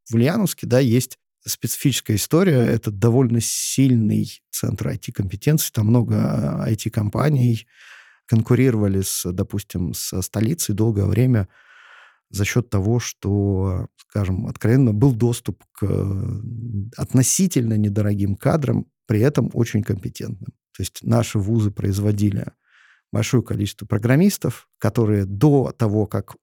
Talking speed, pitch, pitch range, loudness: 115 wpm, 115 Hz, 105-125 Hz, -20 LUFS